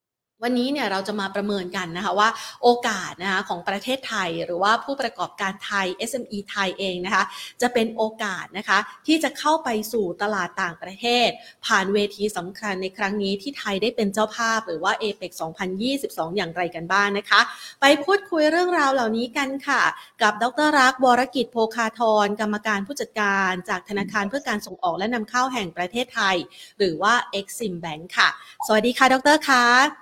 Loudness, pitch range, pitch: -22 LUFS, 195-245 Hz, 215 Hz